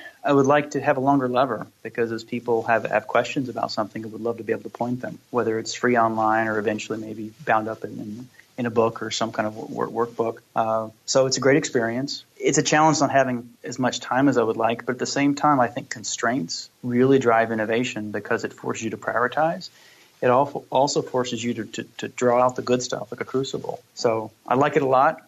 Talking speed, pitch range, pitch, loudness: 240 wpm, 110-135 Hz, 120 Hz, -23 LUFS